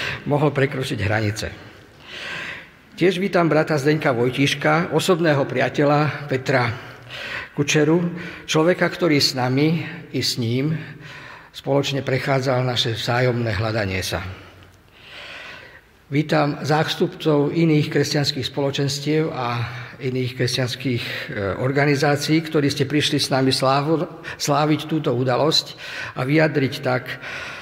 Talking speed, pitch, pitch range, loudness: 100 wpm, 145 Hz, 125-155 Hz, -21 LUFS